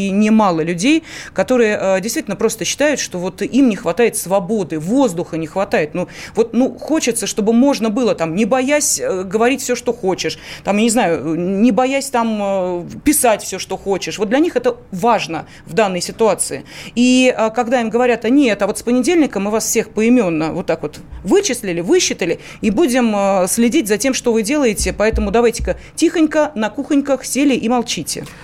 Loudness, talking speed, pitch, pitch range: -16 LUFS, 175 wpm, 225 Hz, 190-255 Hz